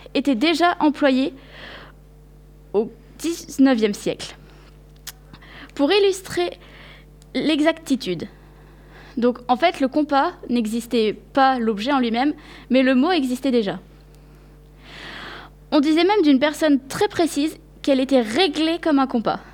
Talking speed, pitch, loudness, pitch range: 115 wpm, 275 Hz, -20 LUFS, 245-315 Hz